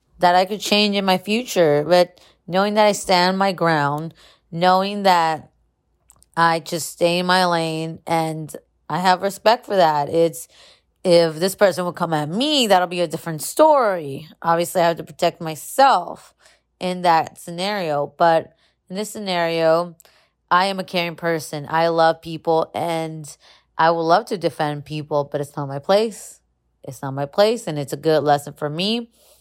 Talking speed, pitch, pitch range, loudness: 175 wpm, 170 Hz, 155-185 Hz, -19 LUFS